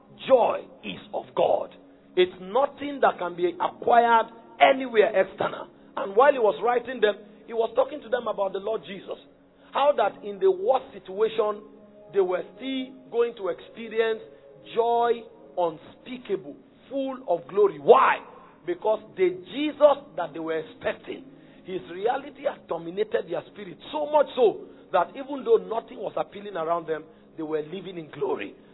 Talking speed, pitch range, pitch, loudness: 155 wpm, 185-270 Hz, 225 Hz, -25 LUFS